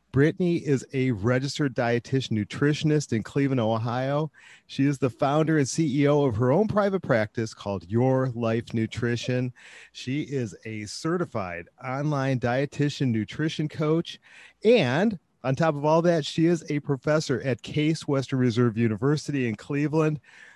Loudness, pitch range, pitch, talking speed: -25 LUFS, 120-150 Hz, 135 Hz, 145 wpm